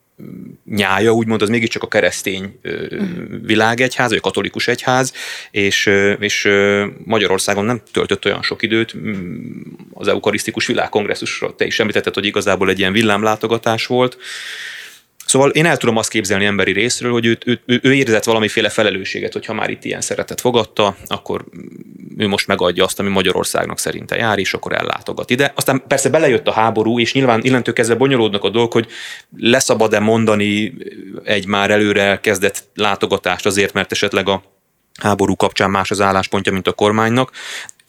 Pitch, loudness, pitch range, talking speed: 110 Hz, -16 LUFS, 100-120 Hz, 155 wpm